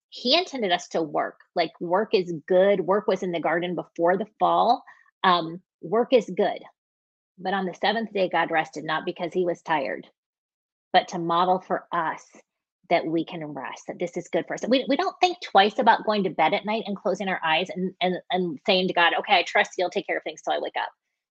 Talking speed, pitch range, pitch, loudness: 230 wpm, 170-200 Hz, 185 Hz, -24 LUFS